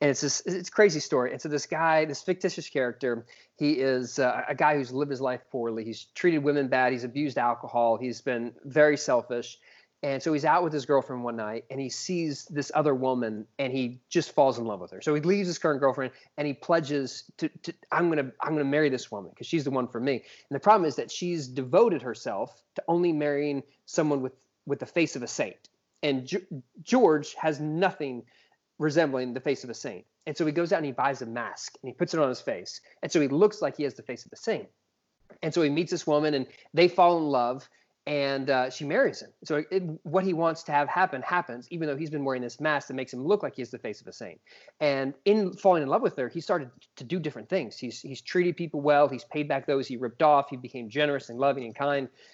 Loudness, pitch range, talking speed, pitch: -28 LUFS, 130-165 Hz, 250 wpm, 145 Hz